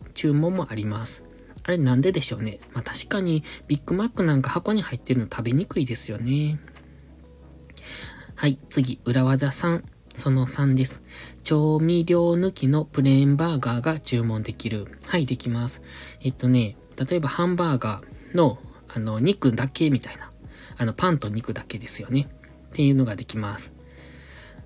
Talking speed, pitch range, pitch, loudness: 315 characters per minute, 110-150 Hz, 130 Hz, -24 LUFS